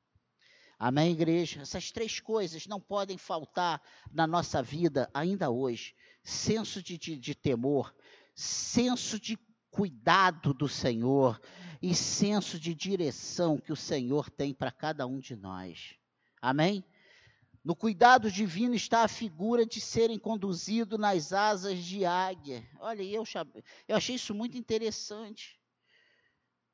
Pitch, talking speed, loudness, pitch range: 180 Hz, 130 wpm, -31 LUFS, 140-215 Hz